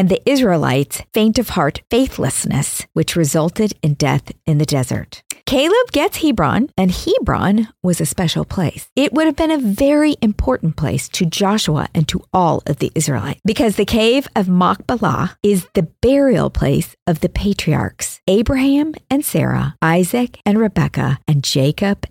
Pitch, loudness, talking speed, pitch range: 195 Hz, -16 LUFS, 160 wpm, 160-245 Hz